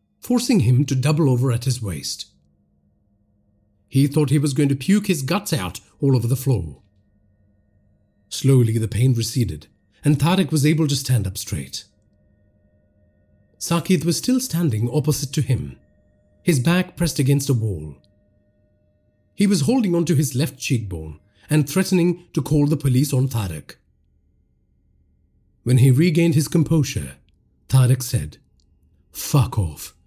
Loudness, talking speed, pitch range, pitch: -20 LUFS, 140 wpm, 100-150 Hz, 115 Hz